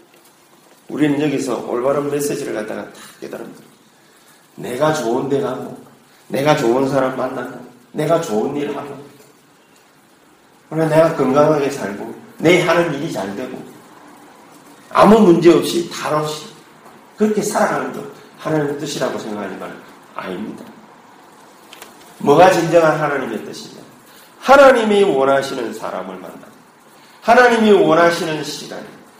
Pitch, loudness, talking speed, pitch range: 150 Hz, -16 LUFS, 265 characters per minute, 135-170 Hz